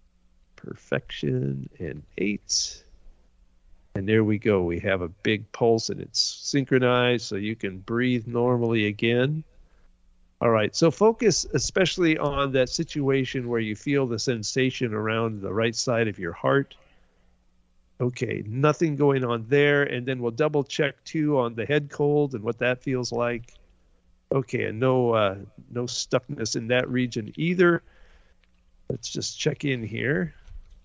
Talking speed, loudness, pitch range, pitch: 150 wpm, -25 LUFS, 100-135 Hz, 120 Hz